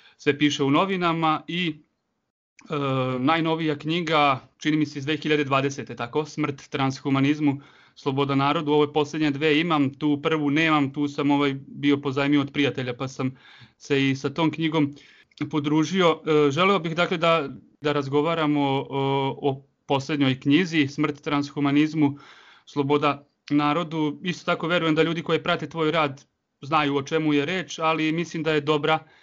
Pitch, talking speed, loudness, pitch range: 150 Hz, 155 wpm, -24 LUFS, 140-155 Hz